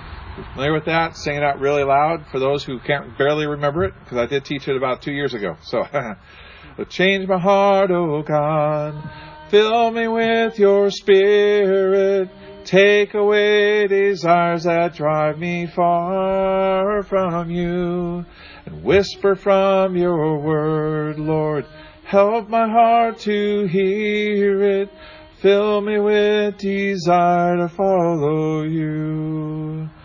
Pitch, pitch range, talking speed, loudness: 175 Hz, 155-200 Hz, 125 wpm, -18 LUFS